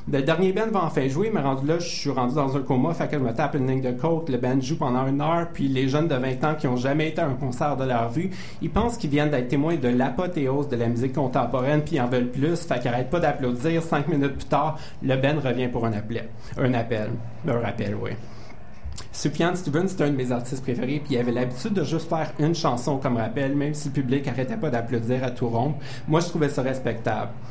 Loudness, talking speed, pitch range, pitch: -25 LUFS, 255 wpm, 125-155 Hz, 135 Hz